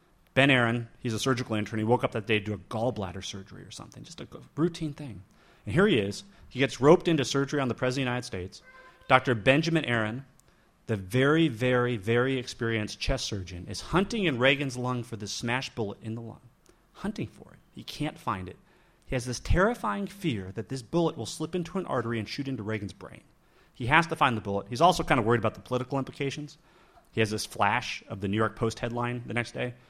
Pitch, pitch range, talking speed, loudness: 125 Hz, 110-140 Hz, 225 wpm, -28 LUFS